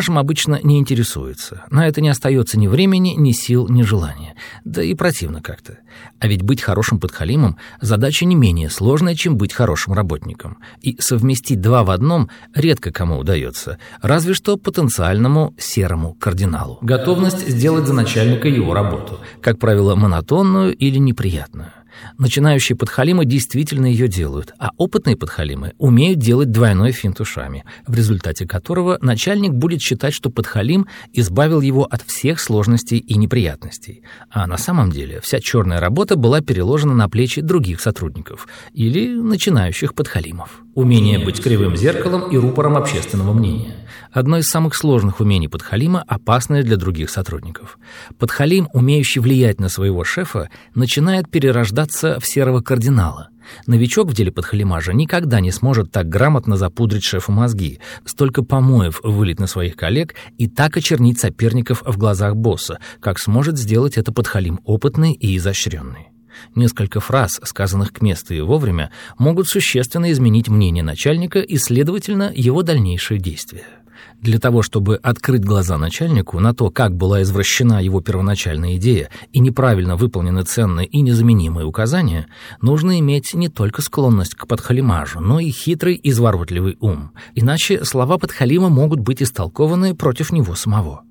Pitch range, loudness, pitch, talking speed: 100-140 Hz, -16 LUFS, 120 Hz, 145 wpm